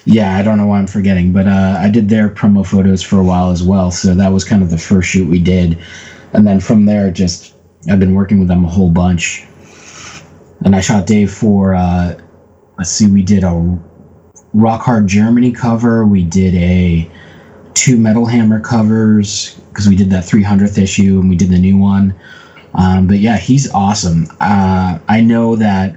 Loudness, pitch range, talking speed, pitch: -11 LUFS, 90-105 Hz, 195 wpm, 95 Hz